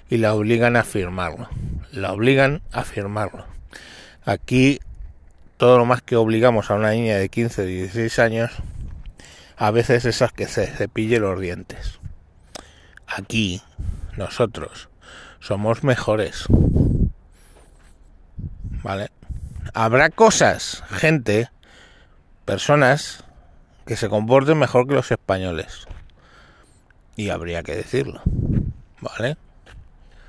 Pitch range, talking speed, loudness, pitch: 90-120 Hz, 100 wpm, -20 LUFS, 100 Hz